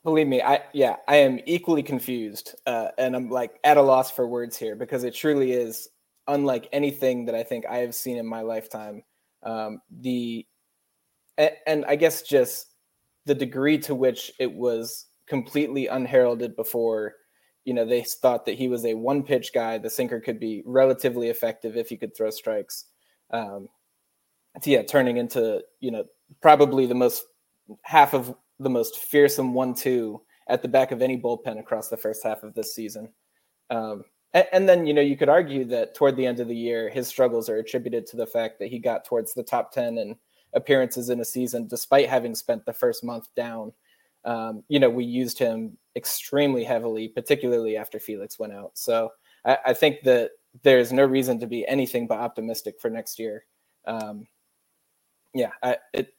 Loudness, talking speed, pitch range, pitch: -24 LUFS, 185 wpm, 115-140 Hz, 125 Hz